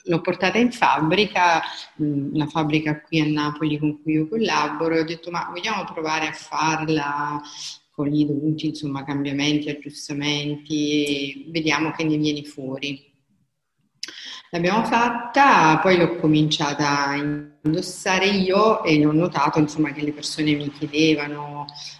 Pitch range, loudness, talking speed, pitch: 145-165 Hz, -21 LUFS, 135 wpm, 150 Hz